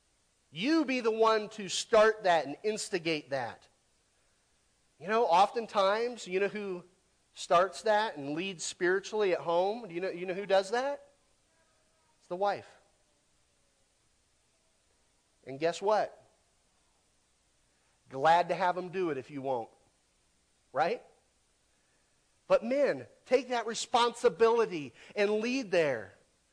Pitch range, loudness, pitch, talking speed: 170-225 Hz, -30 LUFS, 195 Hz, 125 wpm